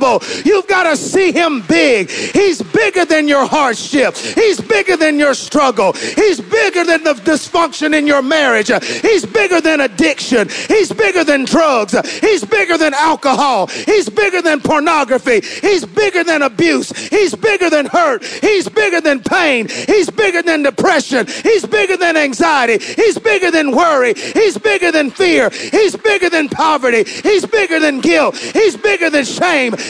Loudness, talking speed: -12 LUFS, 160 wpm